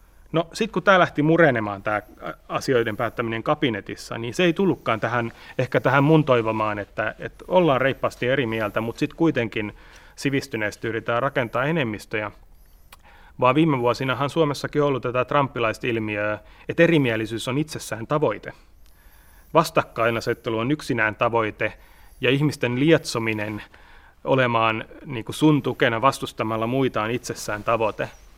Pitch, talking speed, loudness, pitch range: 120 Hz, 125 wpm, -23 LUFS, 110-145 Hz